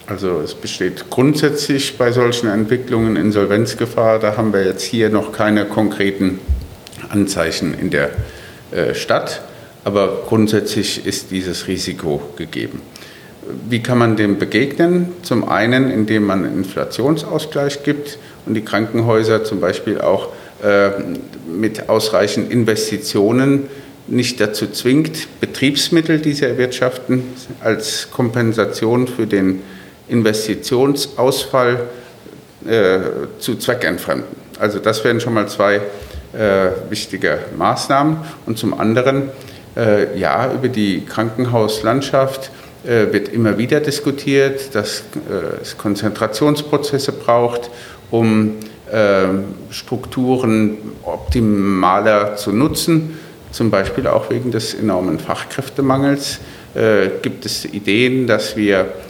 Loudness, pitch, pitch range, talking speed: -17 LUFS, 115 Hz, 105-135 Hz, 110 wpm